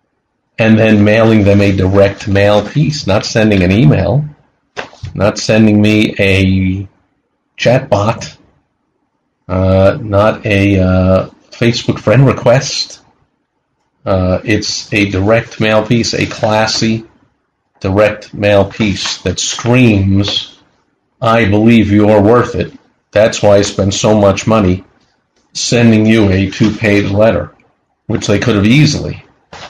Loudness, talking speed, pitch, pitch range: -11 LUFS, 125 wpm, 105 Hz, 100-110 Hz